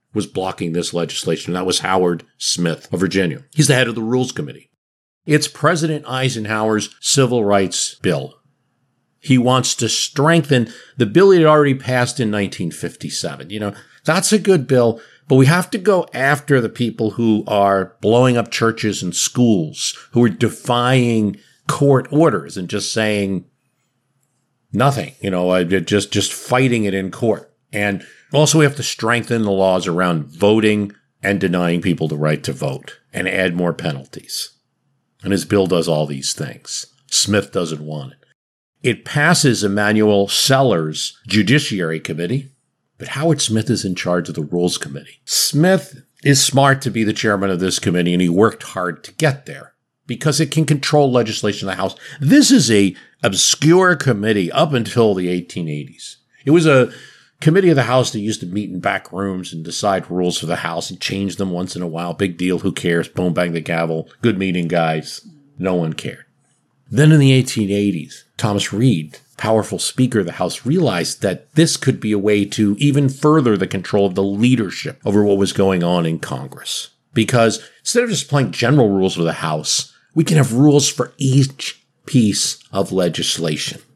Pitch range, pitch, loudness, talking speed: 95-135 Hz, 110 Hz, -17 LUFS, 175 wpm